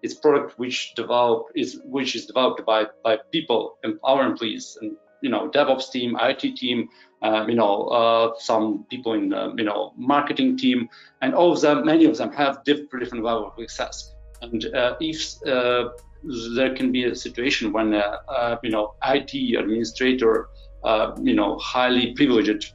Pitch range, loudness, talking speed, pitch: 115-160 Hz, -22 LUFS, 170 wpm, 125 Hz